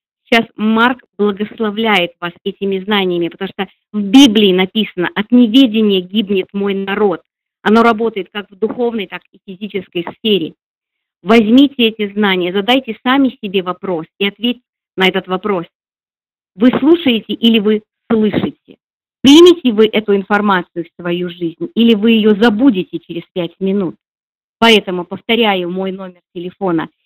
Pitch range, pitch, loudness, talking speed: 185-230 Hz, 205 Hz, -13 LUFS, 140 wpm